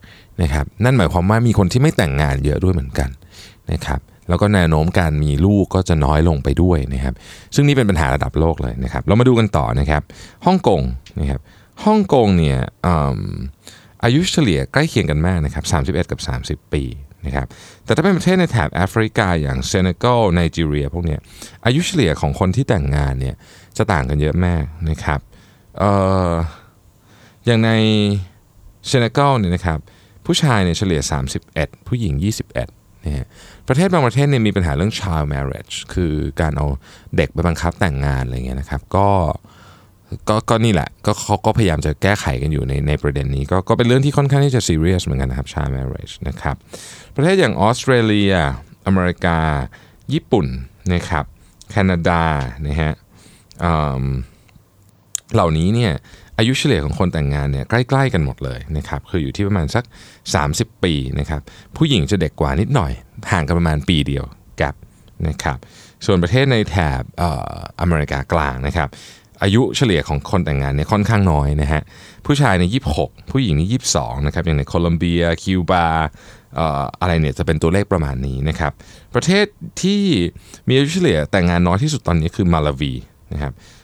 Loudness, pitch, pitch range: -18 LUFS, 90 Hz, 75-105 Hz